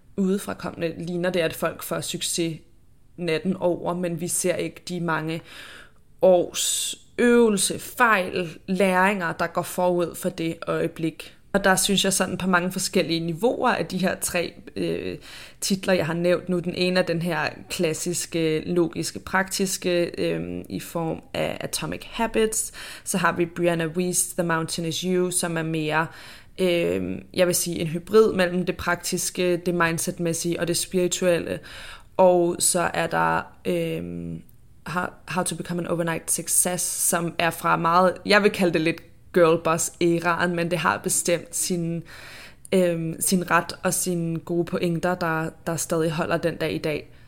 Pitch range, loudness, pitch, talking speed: 165-180 Hz, -23 LUFS, 175 Hz, 160 wpm